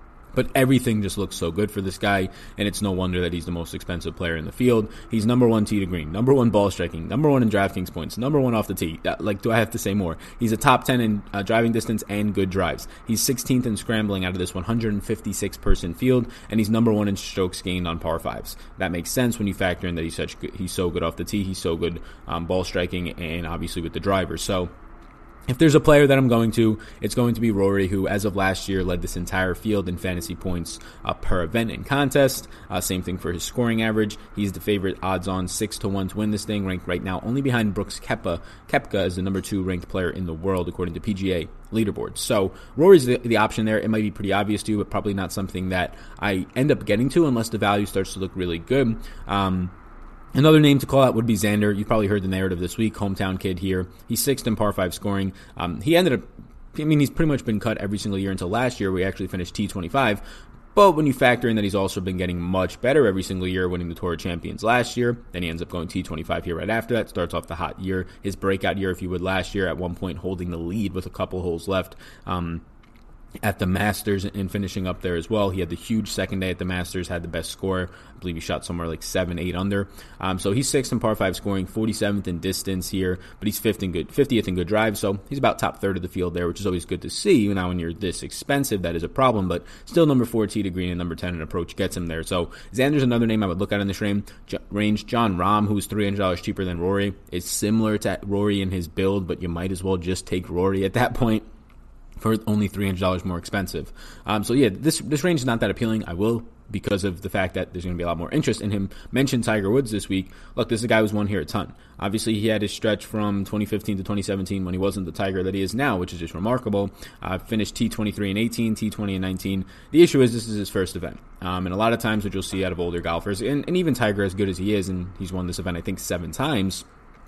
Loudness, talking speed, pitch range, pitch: -24 LUFS, 265 wpm, 90-110 Hz, 100 Hz